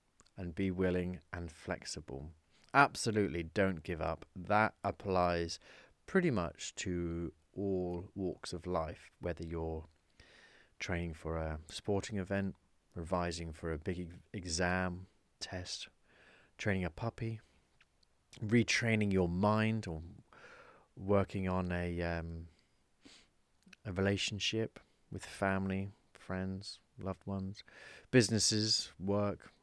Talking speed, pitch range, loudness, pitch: 105 wpm, 85-100 Hz, -36 LUFS, 90 Hz